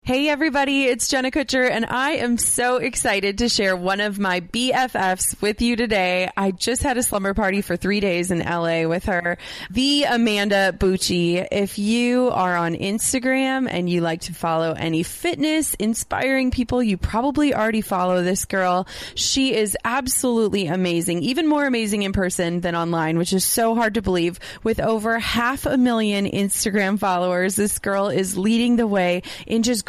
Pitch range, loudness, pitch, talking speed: 185-245 Hz, -20 LUFS, 210 Hz, 175 wpm